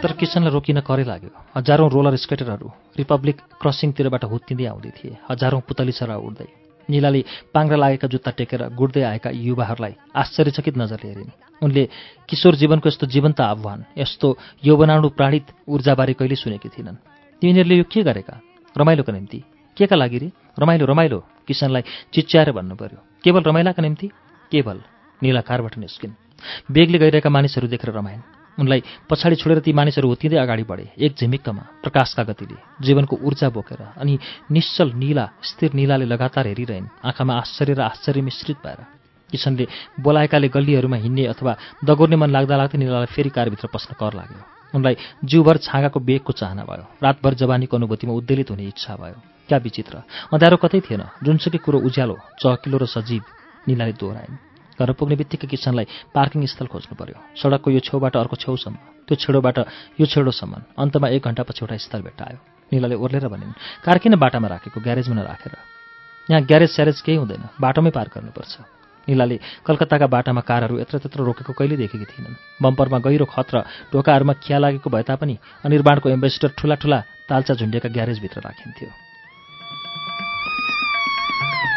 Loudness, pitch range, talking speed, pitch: -19 LUFS, 120-150 Hz, 155 wpm, 135 Hz